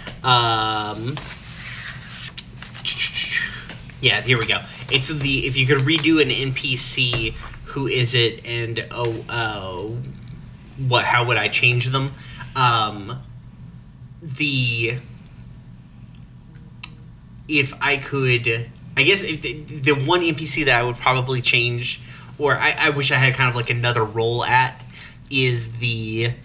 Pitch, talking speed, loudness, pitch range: 125 Hz, 125 wpm, -19 LUFS, 115-135 Hz